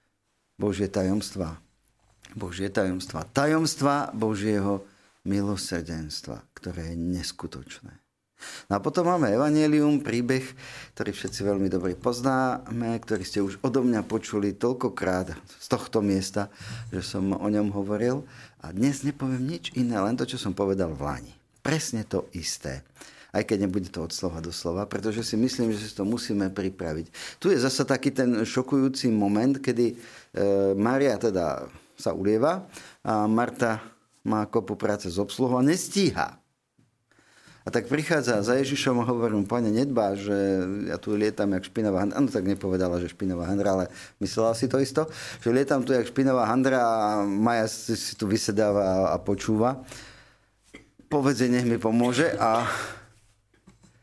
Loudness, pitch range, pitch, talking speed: -26 LUFS, 100-125 Hz, 110 Hz, 150 wpm